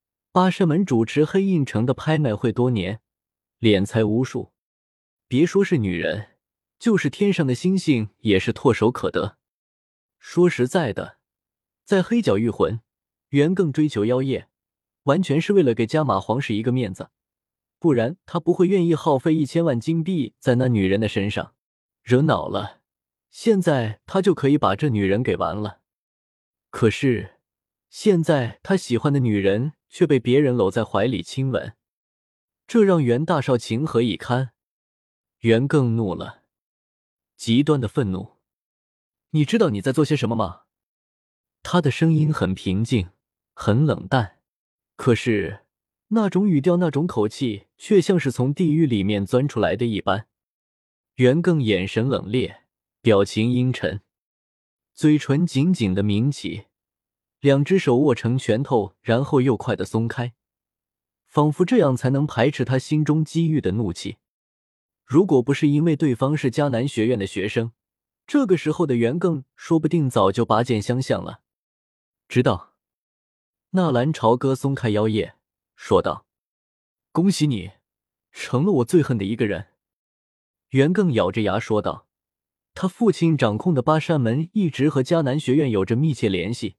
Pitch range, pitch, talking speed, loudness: 105-155 Hz, 125 Hz, 220 characters per minute, -21 LUFS